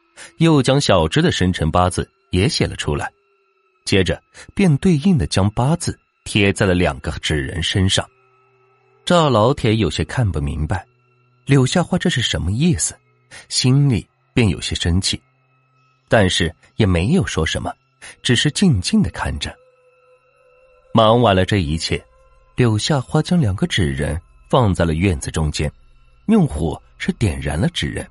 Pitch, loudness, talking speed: 125 Hz, -18 LUFS, 215 characters per minute